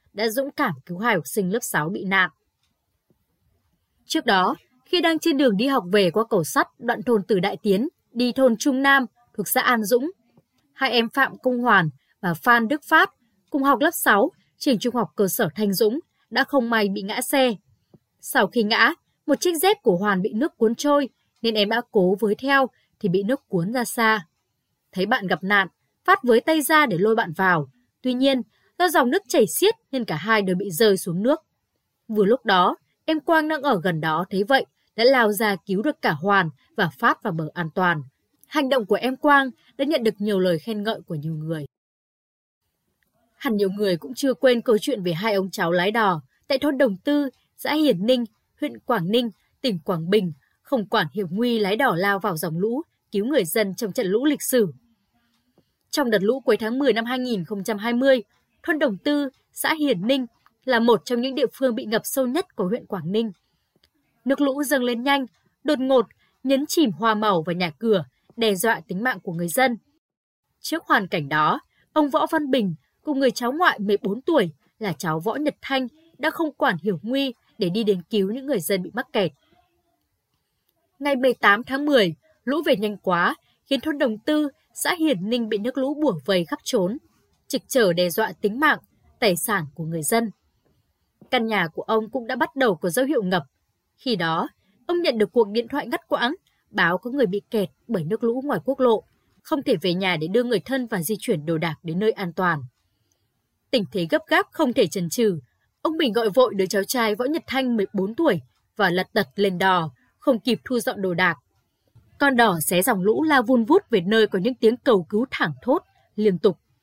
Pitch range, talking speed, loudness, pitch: 190-270 Hz, 210 wpm, -22 LUFS, 225 Hz